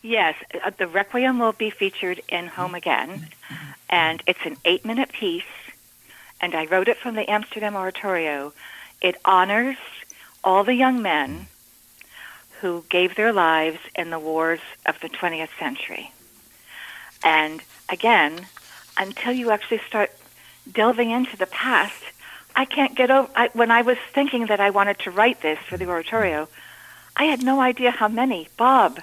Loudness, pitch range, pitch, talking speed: -21 LUFS, 180-245 Hz, 210 Hz, 155 wpm